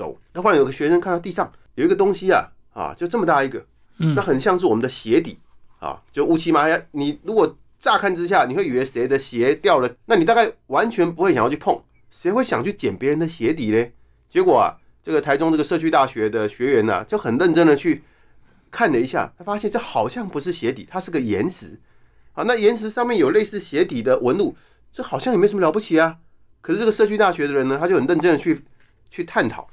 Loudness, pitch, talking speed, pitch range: -20 LUFS, 175 Hz, 340 characters per minute, 145-220 Hz